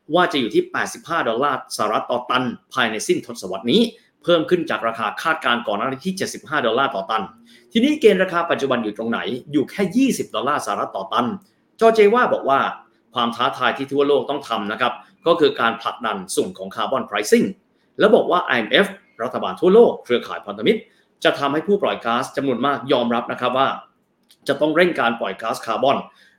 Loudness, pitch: -20 LUFS, 150 Hz